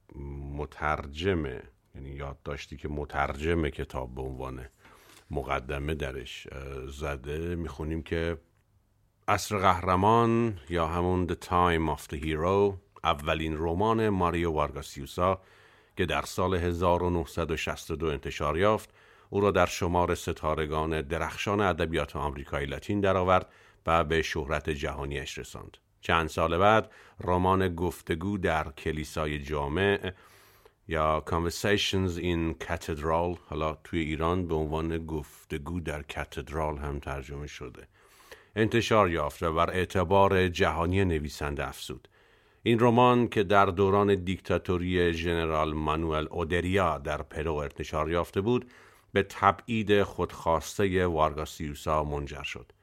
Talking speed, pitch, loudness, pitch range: 110 wpm, 85 Hz, -29 LUFS, 75-95 Hz